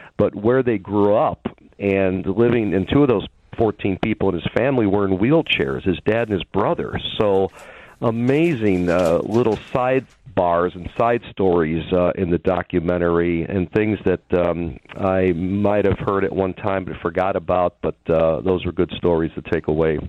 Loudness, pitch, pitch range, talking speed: -20 LUFS, 95 Hz, 90-105 Hz, 175 wpm